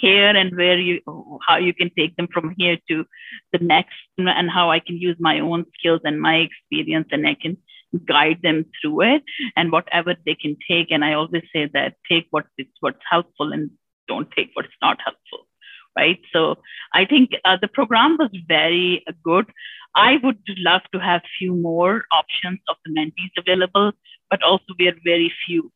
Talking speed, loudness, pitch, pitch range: 190 wpm, -19 LUFS, 175 Hz, 160-190 Hz